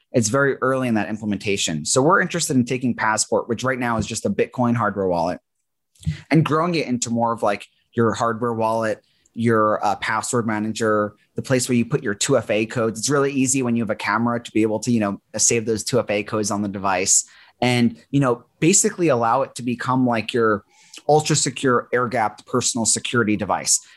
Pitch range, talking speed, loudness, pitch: 110-130 Hz, 210 wpm, -20 LUFS, 115 Hz